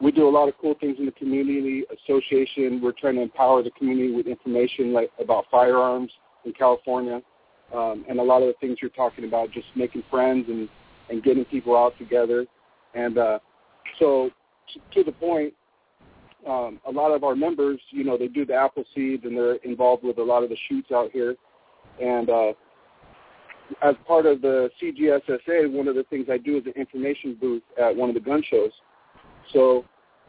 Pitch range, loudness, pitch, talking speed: 120-140 Hz, -23 LUFS, 130 Hz, 195 wpm